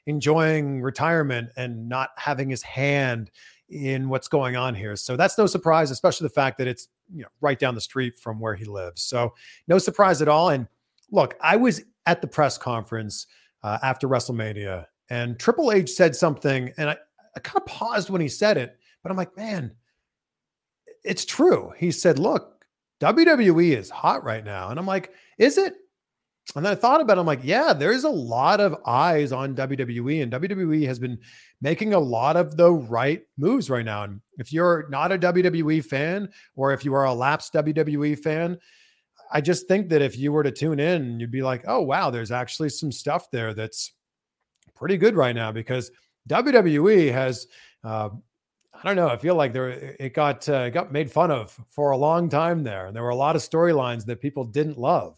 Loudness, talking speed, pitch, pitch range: -23 LUFS, 200 wpm, 145 Hz, 125-170 Hz